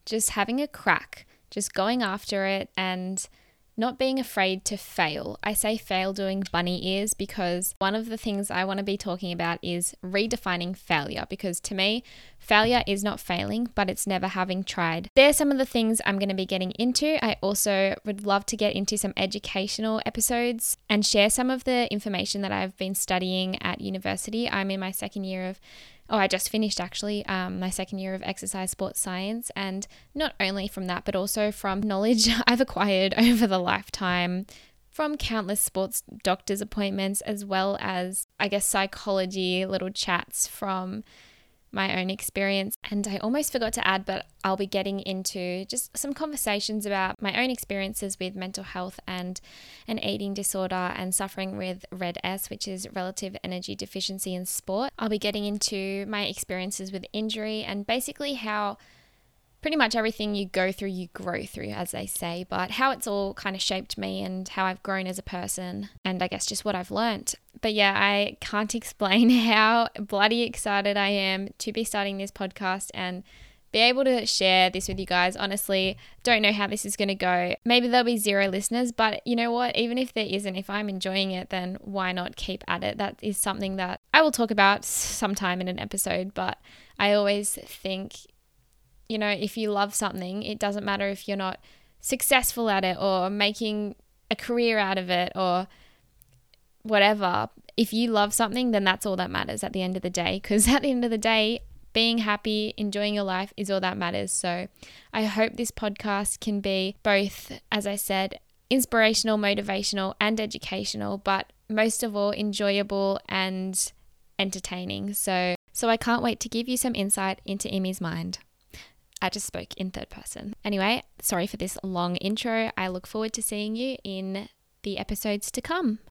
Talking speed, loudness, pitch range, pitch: 190 wpm, -26 LUFS, 190-220 Hz, 200 Hz